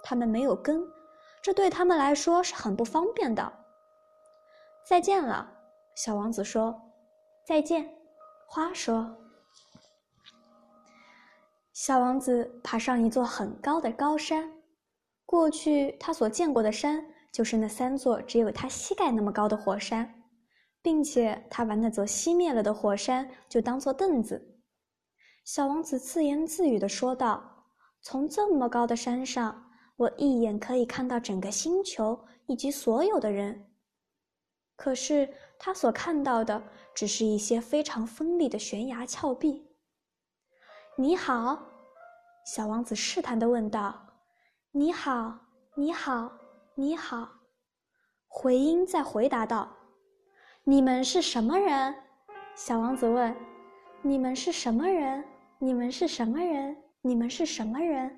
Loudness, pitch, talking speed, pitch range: -29 LUFS, 265 Hz, 190 characters per minute, 230-315 Hz